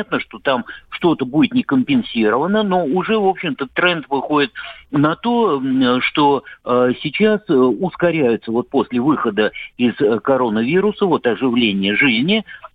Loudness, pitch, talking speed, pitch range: -17 LUFS, 165 Hz, 115 wpm, 130-215 Hz